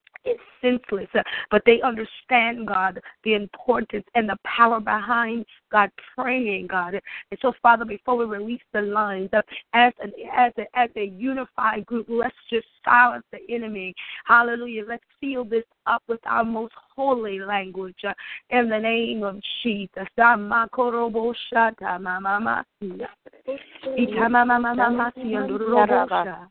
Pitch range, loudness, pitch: 210-245 Hz, -22 LUFS, 230 Hz